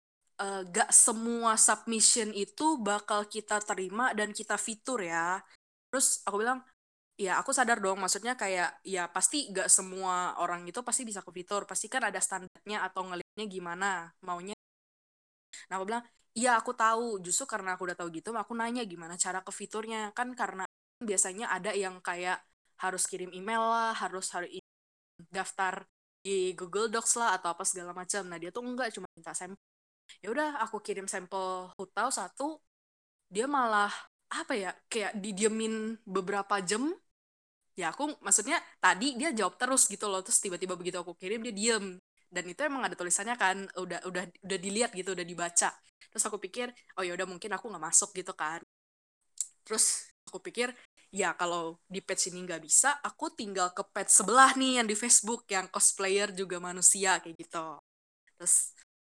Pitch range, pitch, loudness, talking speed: 185-225 Hz, 200 Hz, -30 LUFS, 170 wpm